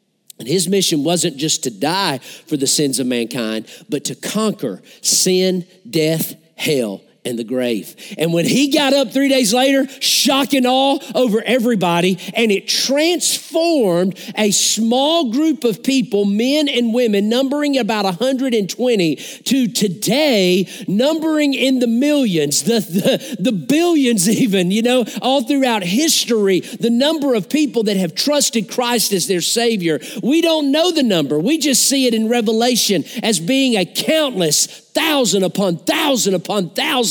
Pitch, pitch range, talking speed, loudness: 230 Hz, 185-270 Hz, 155 wpm, -16 LUFS